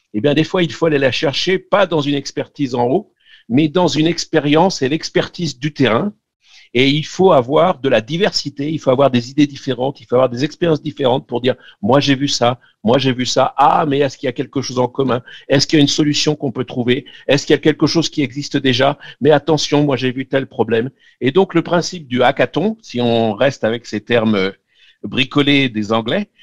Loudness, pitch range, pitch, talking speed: -16 LUFS, 130-155 Hz, 140 Hz, 230 wpm